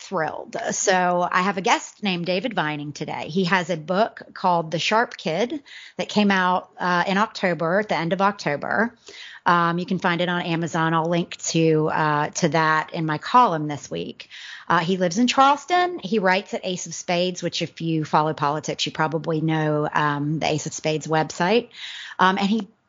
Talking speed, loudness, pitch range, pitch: 195 wpm, -22 LUFS, 155-200 Hz, 175 Hz